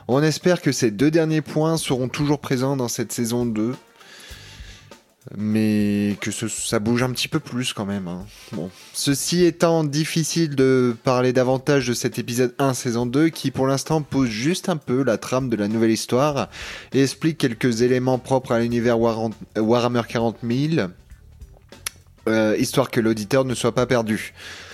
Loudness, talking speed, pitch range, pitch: -21 LUFS, 170 wpm, 115-140 Hz, 125 Hz